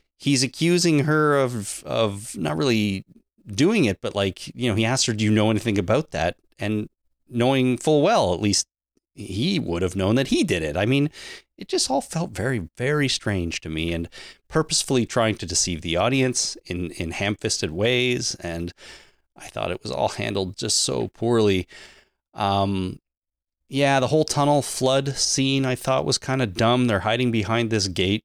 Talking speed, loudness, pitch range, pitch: 185 wpm, -22 LUFS, 95-135 Hz, 115 Hz